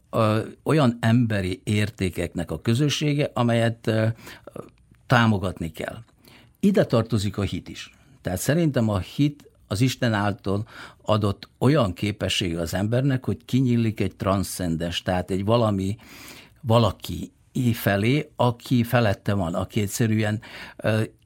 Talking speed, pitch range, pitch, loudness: 115 wpm, 95-120 Hz, 110 Hz, -24 LUFS